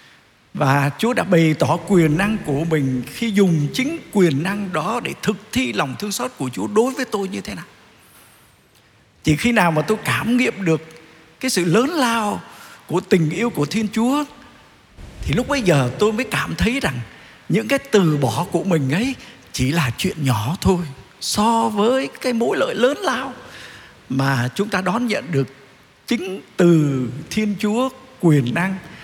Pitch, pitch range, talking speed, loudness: 180 Hz, 145-225 Hz, 180 wpm, -19 LUFS